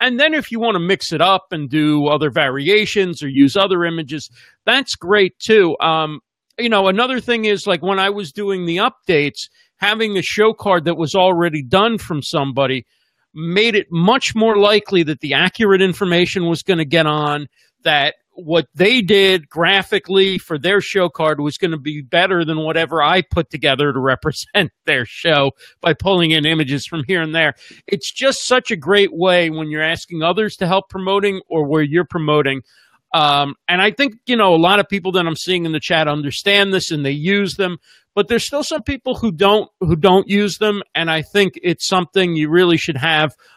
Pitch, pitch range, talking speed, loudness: 180 Hz, 155-200 Hz, 200 wpm, -16 LUFS